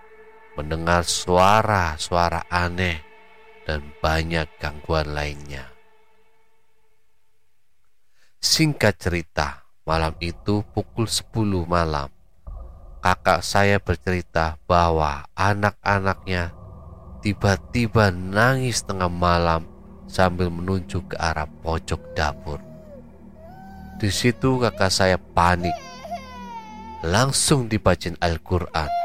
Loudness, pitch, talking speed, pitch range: -22 LUFS, 90 Hz, 75 wpm, 85-110 Hz